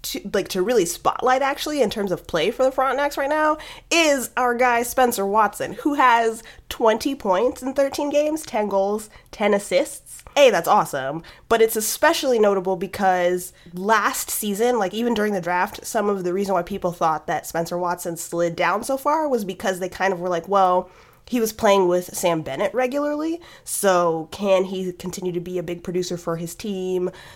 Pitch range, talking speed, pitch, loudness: 180-255 Hz, 190 wpm, 205 Hz, -21 LUFS